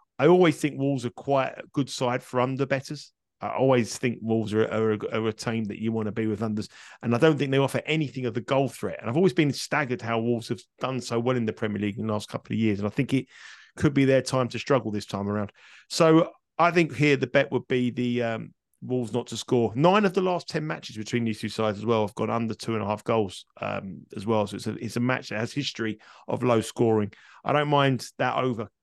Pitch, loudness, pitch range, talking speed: 120 Hz, -26 LUFS, 110-135 Hz, 265 wpm